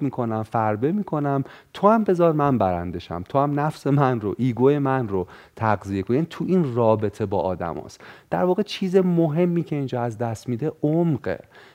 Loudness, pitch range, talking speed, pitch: -23 LUFS, 110-165 Hz, 175 wpm, 135 Hz